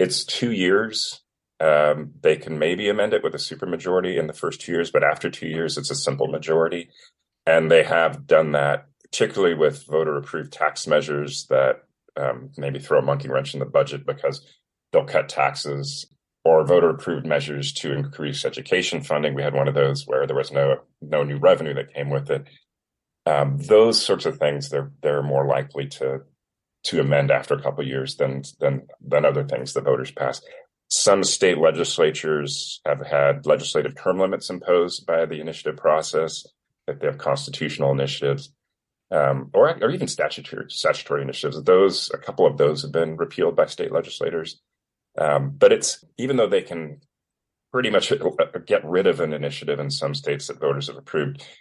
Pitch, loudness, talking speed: 80 Hz, -22 LUFS, 180 wpm